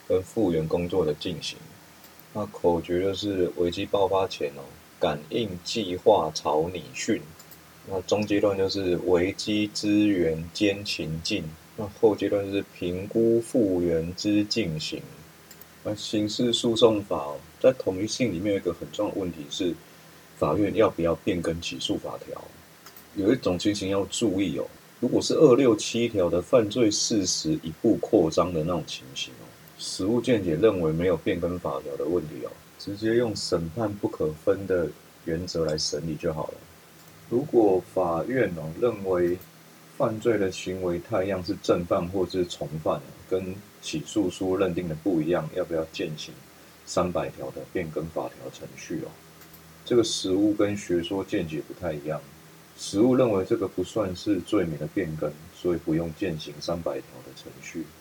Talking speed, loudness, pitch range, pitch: 245 characters per minute, -26 LUFS, 80-105 Hz, 95 Hz